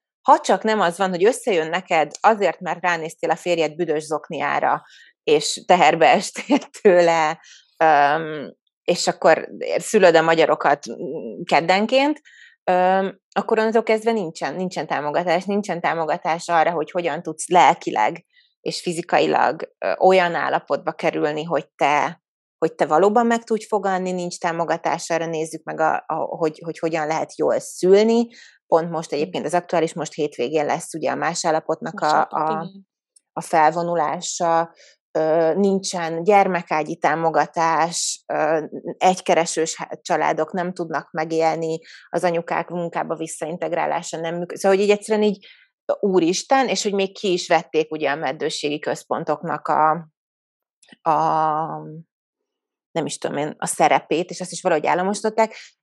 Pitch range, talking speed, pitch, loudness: 160-195 Hz, 130 wpm, 170 Hz, -20 LUFS